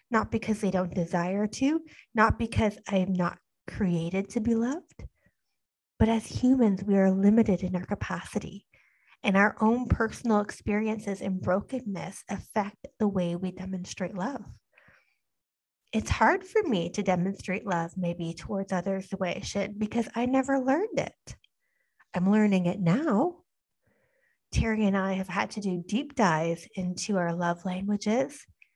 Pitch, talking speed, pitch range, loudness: 200 Hz, 150 wpm, 185-225 Hz, -28 LUFS